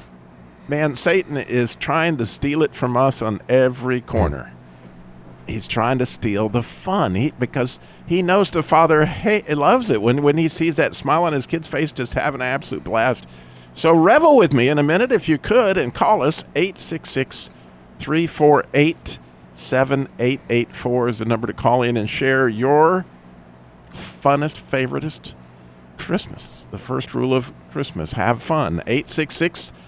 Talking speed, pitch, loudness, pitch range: 155 wpm, 125 Hz, -19 LUFS, 90-150 Hz